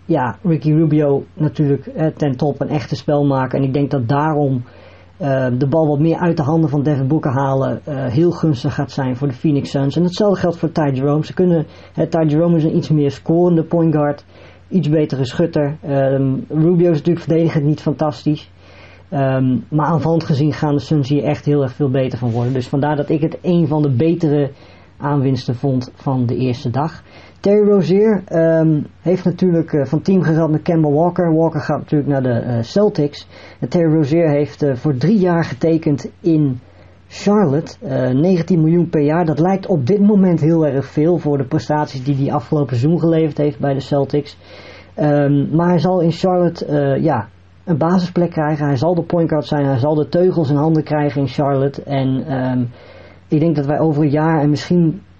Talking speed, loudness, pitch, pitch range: 205 wpm, -16 LUFS, 150 Hz, 140-165 Hz